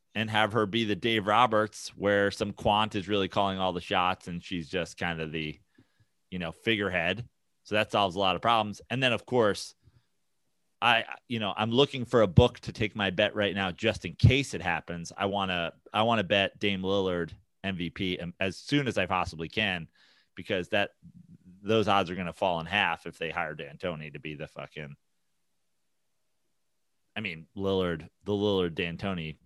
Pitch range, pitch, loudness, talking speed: 90-110 Hz, 100 Hz, -28 LUFS, 200 wpm